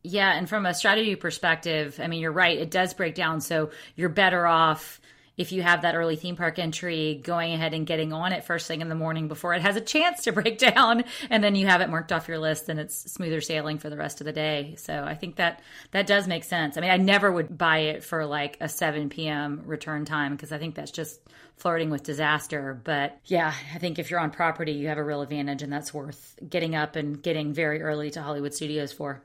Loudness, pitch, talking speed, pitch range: -26 LUFS, 160 Hz, 245 wpm, 150-175 Hz